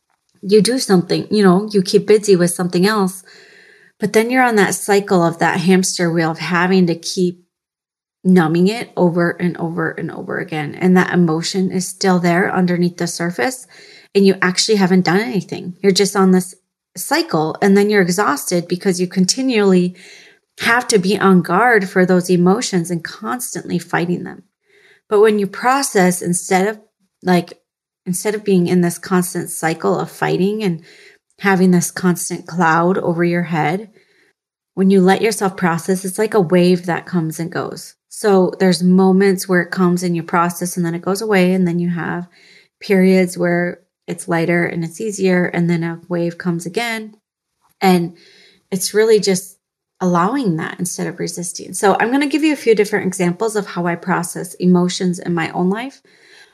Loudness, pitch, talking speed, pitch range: -16 LUFS, 185 Hz, 180 wpm, 175-200 Hz